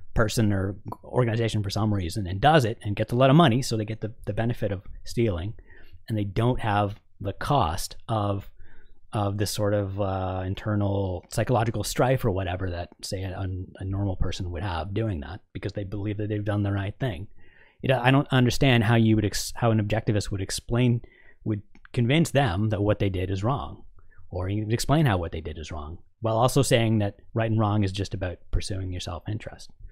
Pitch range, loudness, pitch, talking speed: 95-115 Hz, -26 LUFS, 105 Hz, 210 wpm